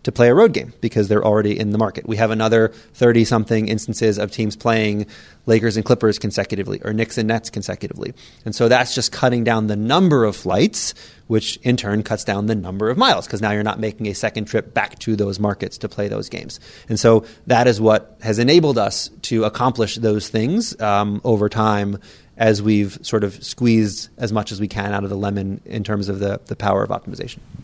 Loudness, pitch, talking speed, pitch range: -19 LUFS, 110 Hz, 220 wpm, 105-115 Hz